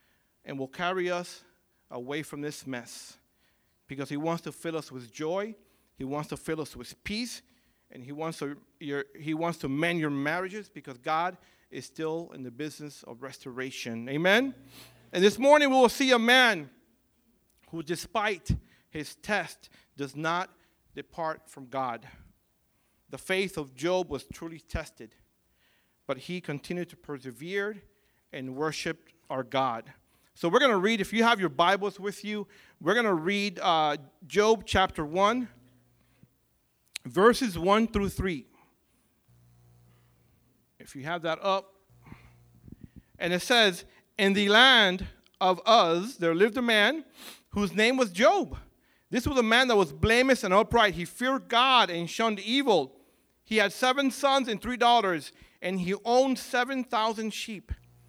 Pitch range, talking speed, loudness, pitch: 140-210 Hz, 155 wpm, -27 LUFS, 175 Hz